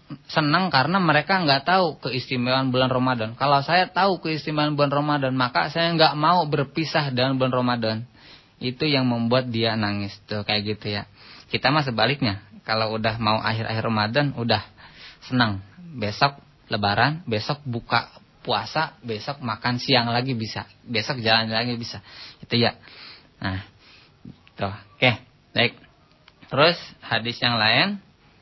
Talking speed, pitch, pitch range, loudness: 135 wpm, 125 Hz, 110-145 Hz, -22 LUFS